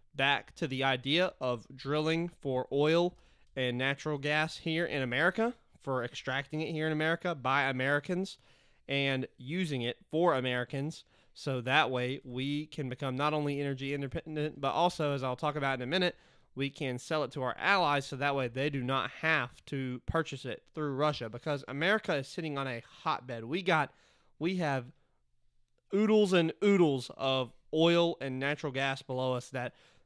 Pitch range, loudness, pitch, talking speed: 130-160 Hz, -32 LUFS, 140 Hz, 175 wpm